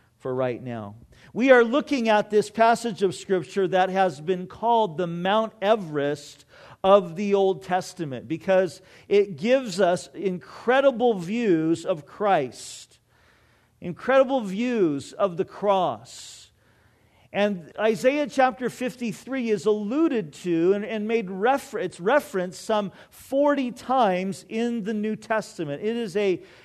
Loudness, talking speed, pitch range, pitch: -24 LUFS, 130 wpm, 175-230 Hz, 200 Hz